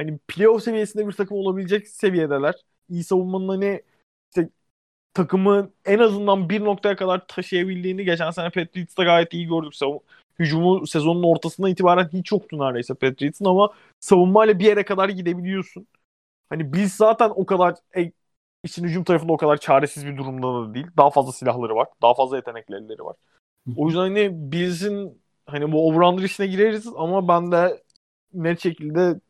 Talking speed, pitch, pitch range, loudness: 155 wpm, 180 Hz, 155-195 Hz, -21 LUFS